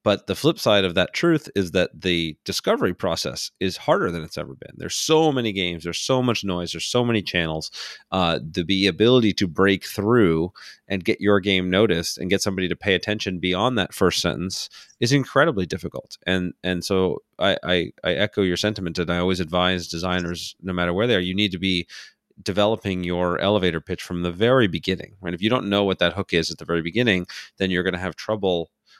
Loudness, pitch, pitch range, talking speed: -22 LUFS, 95 Hz, 90-100 Hz, 215 wpm